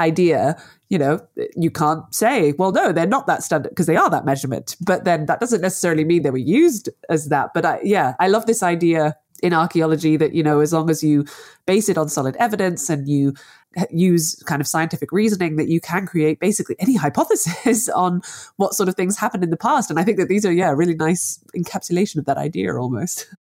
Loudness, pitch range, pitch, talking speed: -19 LUFS, 155-190 Hz, 170 Hz, 220 wpm